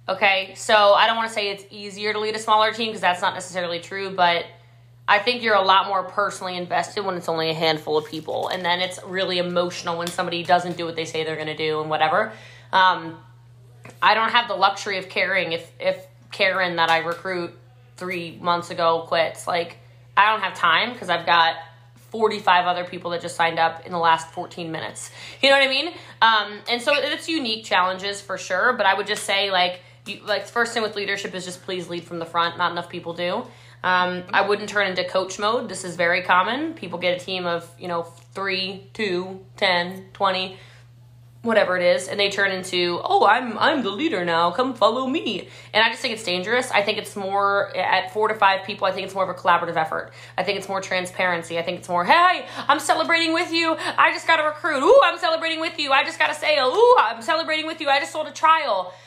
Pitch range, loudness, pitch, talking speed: 170-215 Hz, -21 LUFS, 185 Hz, 230 wpm